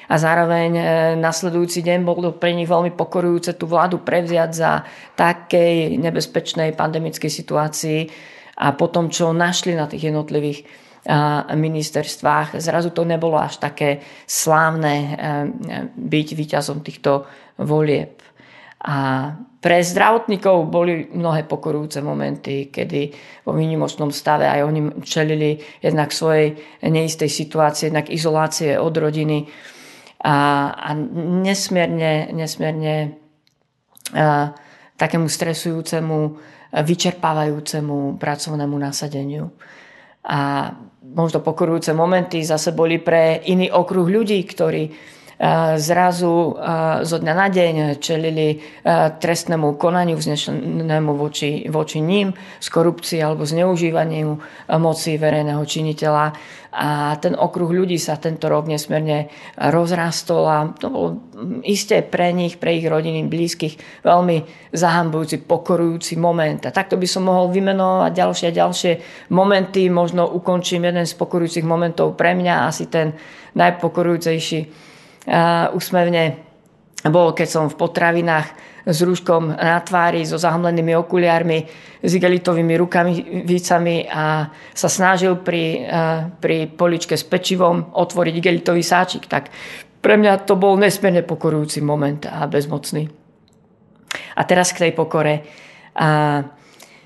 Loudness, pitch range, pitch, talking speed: -18 LUFS, 150-175 Hz, 160 Hz, 115 wpm